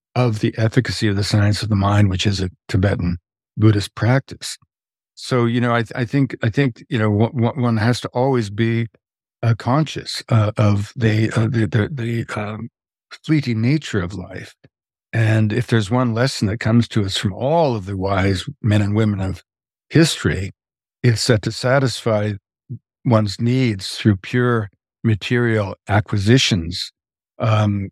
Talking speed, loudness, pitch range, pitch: 160 wpm, -19 LUFS, 105-120 Hz, 110 Hz